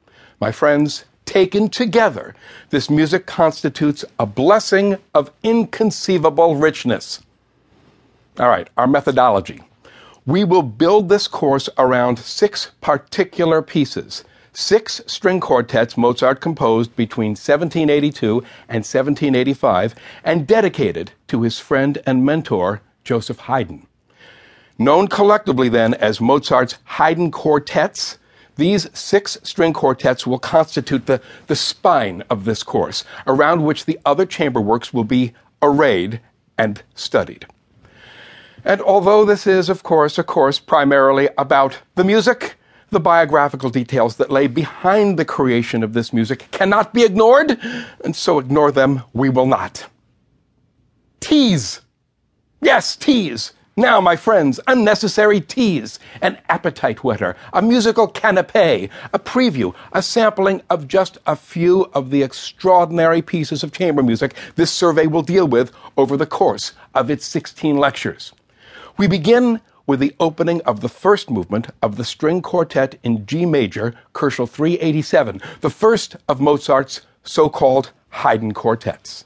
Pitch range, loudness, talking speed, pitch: 130-185 Hz, -16 LUFS, 130 wpm, 150 Hz